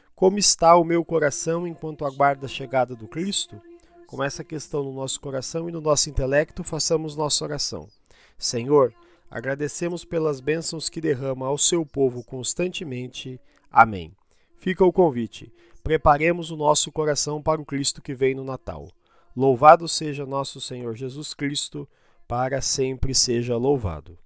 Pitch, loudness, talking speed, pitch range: 145 Hz, -22 LUFS, 145 wpm, 130-165 Hz